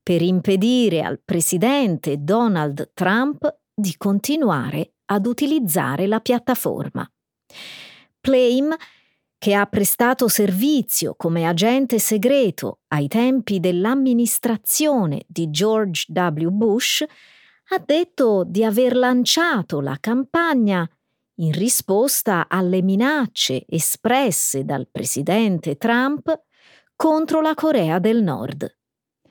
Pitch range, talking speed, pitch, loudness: 175-255 Hz, 95 wpm, 215 Hz, -19 LUFS